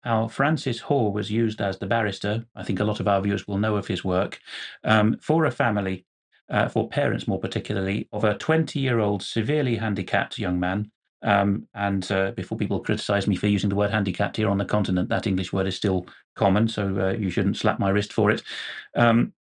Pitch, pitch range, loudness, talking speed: 105 Hz, 100-115 Hz, -24 LUFS, 210 wpm